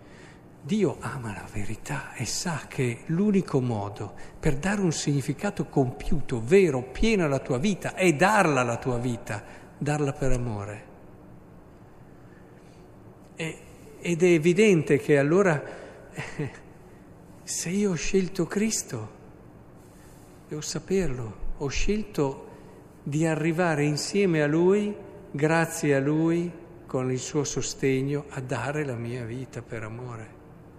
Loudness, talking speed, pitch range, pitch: -26 LUFS, 120 wpm, 125-175 Hz, 145 Hz